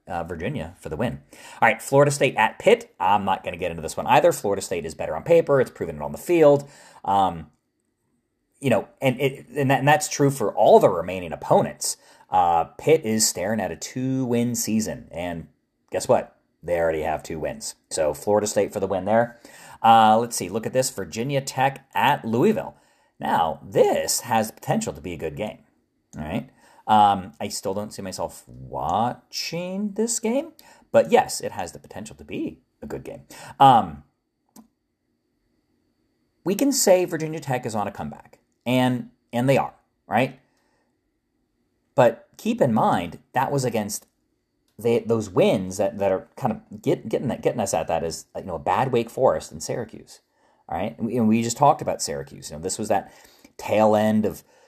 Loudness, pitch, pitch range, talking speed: -23 LUFS, 120 Hz, 105-145 Hz, 195 wpm